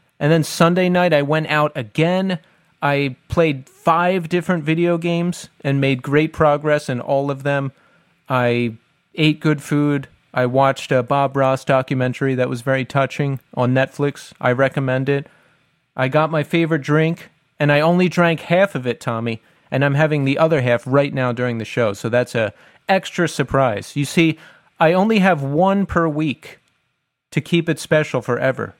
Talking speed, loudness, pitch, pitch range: 175 wpm, -18 LUFS, 145 Hz, 130-165 Hz